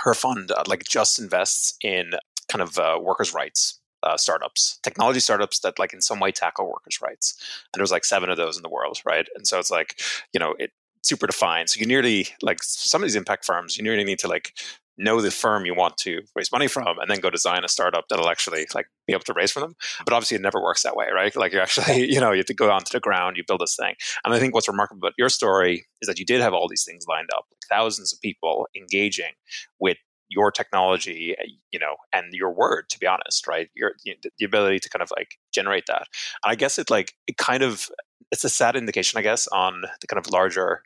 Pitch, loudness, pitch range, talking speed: 100 Hz, -23 LUFS, 95-120 Hz, 245 wpm